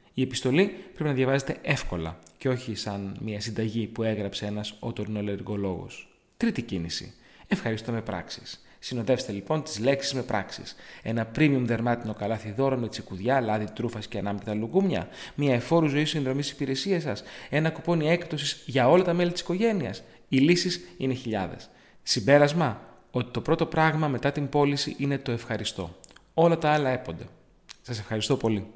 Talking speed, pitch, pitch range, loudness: 155 wpm, 125 Hz, 110-150 Hz, -27 LUFS